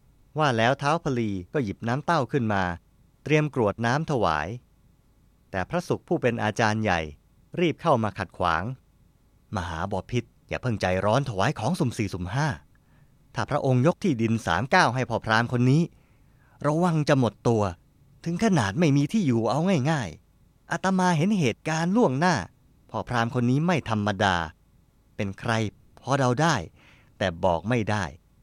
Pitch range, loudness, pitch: 105-145 Hz, -25 LUFS, 125 Hz